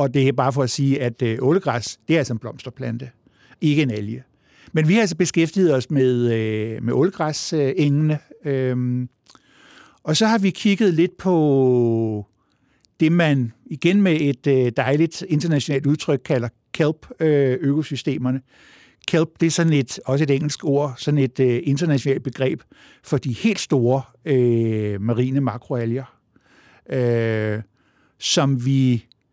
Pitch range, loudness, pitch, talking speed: 125-155 Hz, -20 LUFS, 135 Hz, 150 wpm